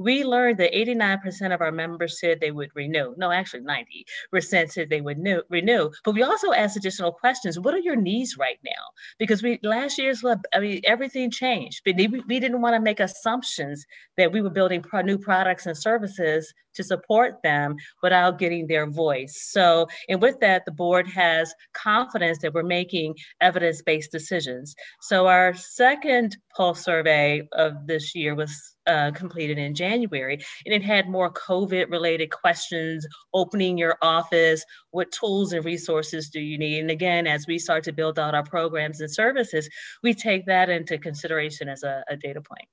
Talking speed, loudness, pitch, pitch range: 175 wpm, -23 LUFS, 175 Hz, 160-210 Hz